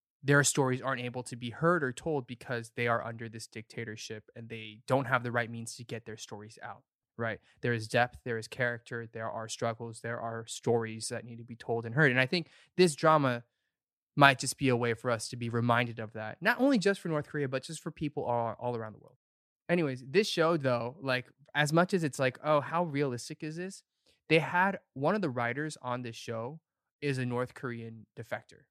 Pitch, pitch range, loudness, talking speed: 125 Hz, 115-150 Hz, -31 LUFS, 225 wpm